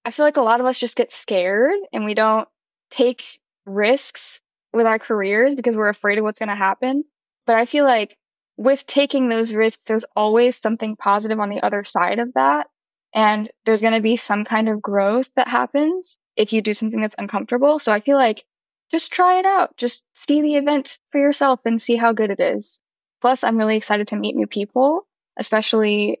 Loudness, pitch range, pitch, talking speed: -19 LUFS, 210-265 Hz, 225 Hz, 205 wpm